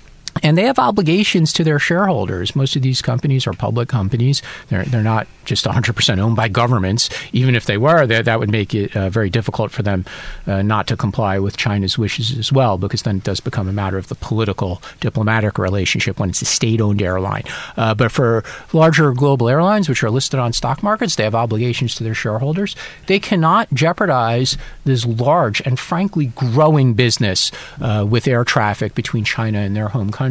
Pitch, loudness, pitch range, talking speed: 120 Hz, -17 LUFS, 110-140 Hz, 195 wpm